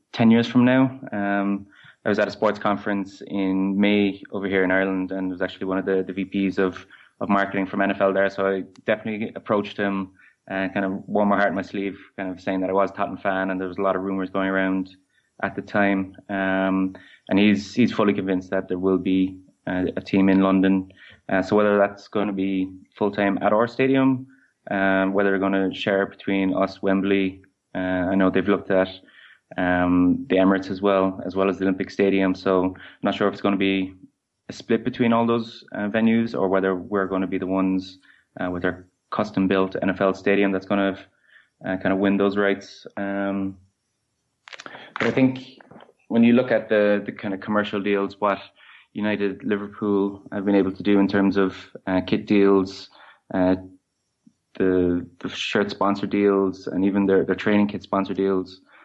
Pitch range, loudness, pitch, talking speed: 95-100 Hz, -22 LUFS, 95 Hz, 205 wpm